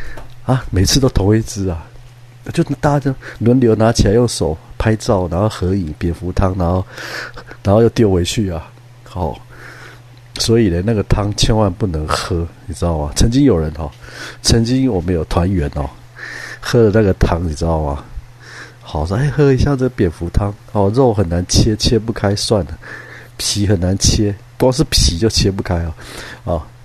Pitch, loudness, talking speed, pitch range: 110 Hz, -16 LUFS, 245 characters per minute, 90-120 Hz